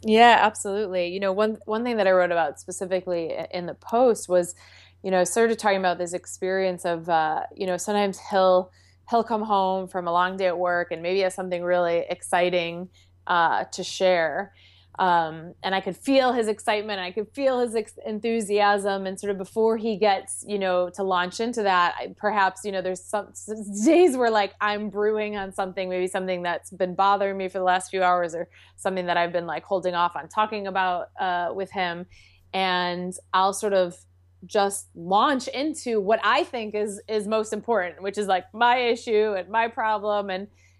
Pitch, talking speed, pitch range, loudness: 190 Hz, 200 wpm, 180-215 Hz, -24 LUFS